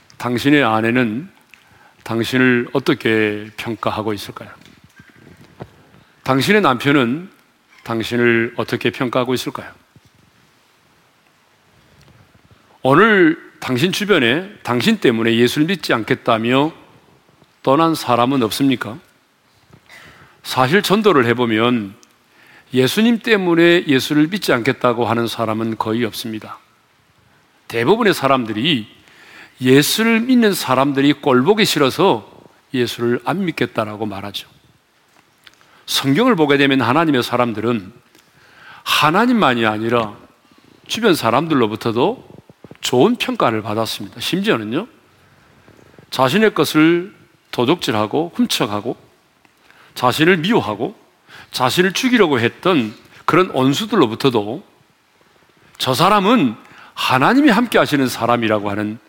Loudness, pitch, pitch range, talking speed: -16 LUFS, 130 Hz, 115-165 Hz, 250 characters per minute